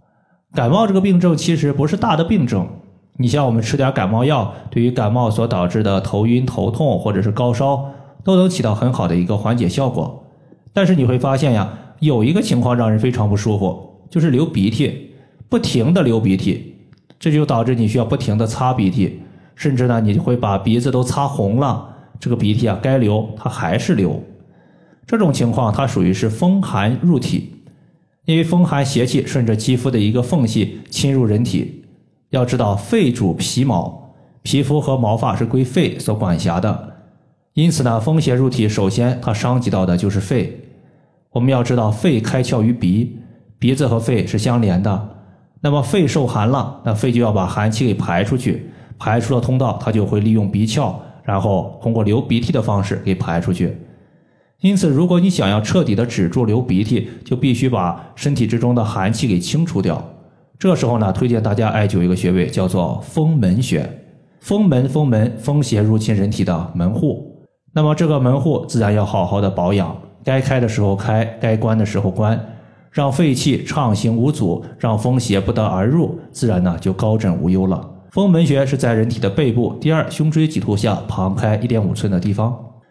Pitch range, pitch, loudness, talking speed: 105-140 Hz, 120 Hz, -17 LUFS, 280 characters per minute